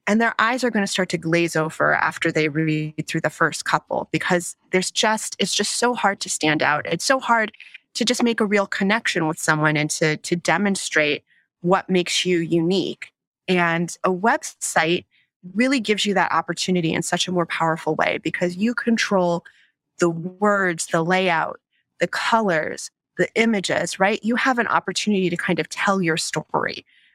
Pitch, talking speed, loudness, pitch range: 180 Hz, 180 wpm, -21 LUFS, 165-205 Hz